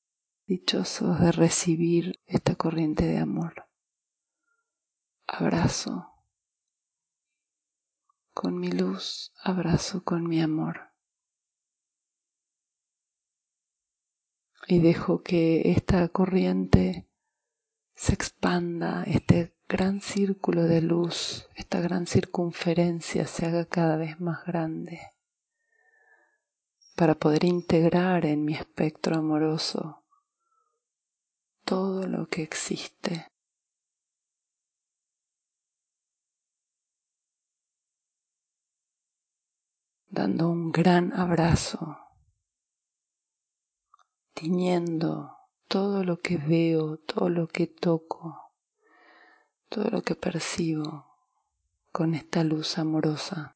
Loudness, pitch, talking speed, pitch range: -27 LUFS, 170 Hz, 75 wpm, 160-185 Hz